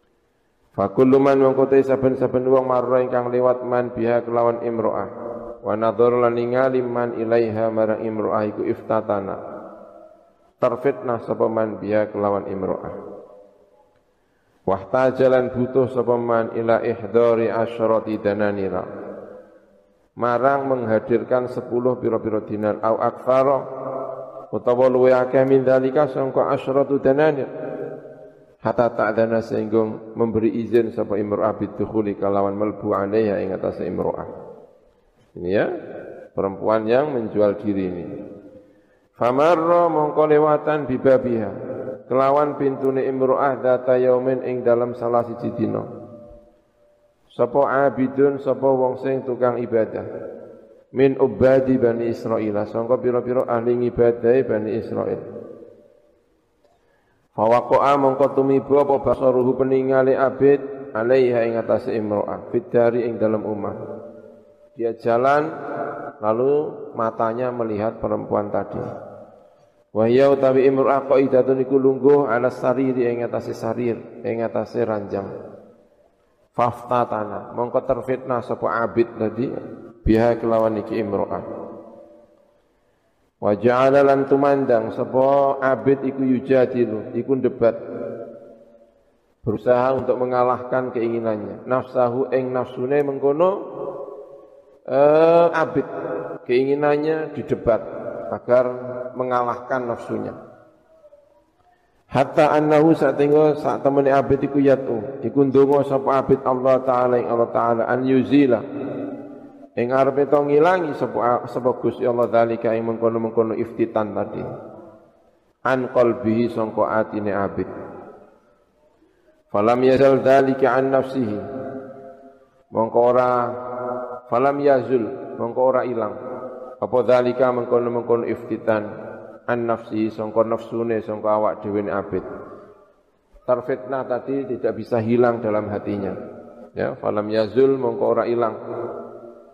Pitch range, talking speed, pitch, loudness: 115-135 Hz, 110 wpm, 125 Hz, -20 LUFS